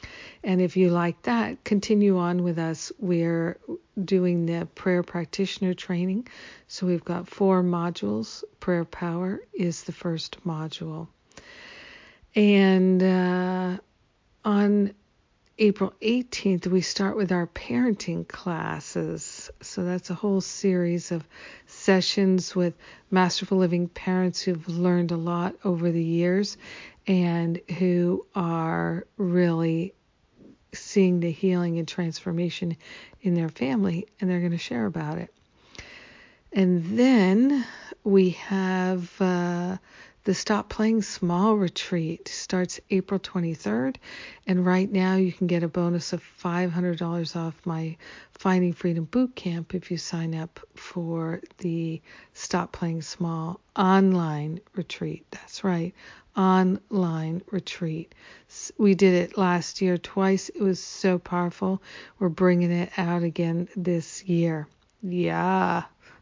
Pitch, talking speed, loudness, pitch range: 180 Hz, 125 wpm, -26 LUFS, 170-195 Hz